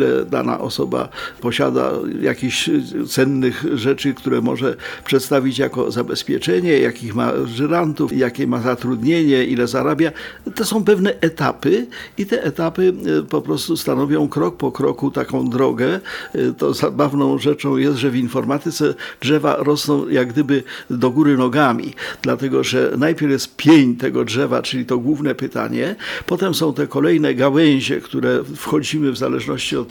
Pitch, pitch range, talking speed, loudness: 140 Hz, 130-150 Hz, 140 wpm, -18 LUFS